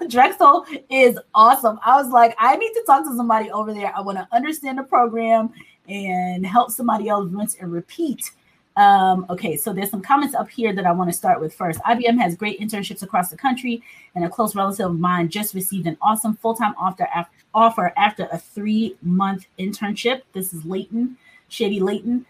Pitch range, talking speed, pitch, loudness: 190-245 Hz, 195 wpm, 215 Hz, -19 LUFS